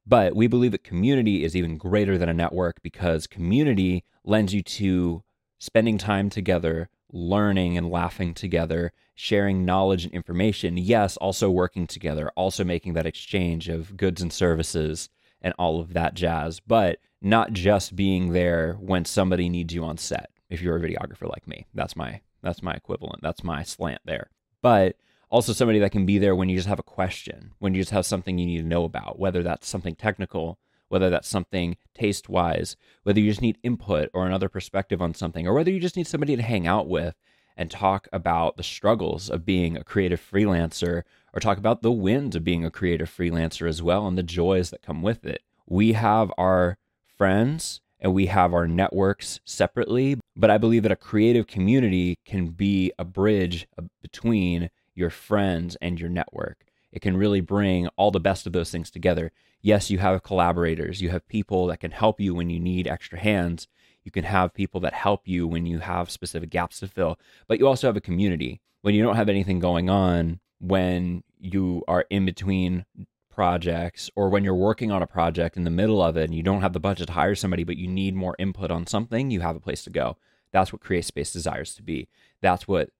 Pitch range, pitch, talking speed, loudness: 85-100 Hz, 95 Hz, 205 wpm, -24 LUFS